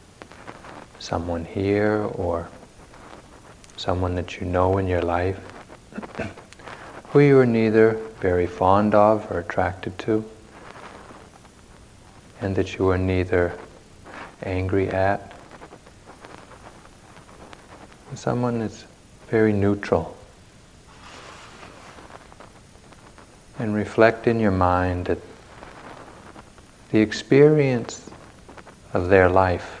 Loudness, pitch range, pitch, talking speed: -21 LUFS, 90-110 Hz, 100 Hz, 85 wpm